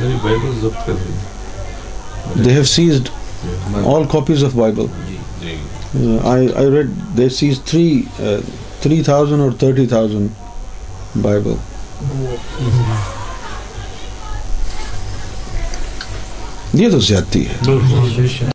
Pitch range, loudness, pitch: 95-130 Hz, -16 LUFS, 110 Hz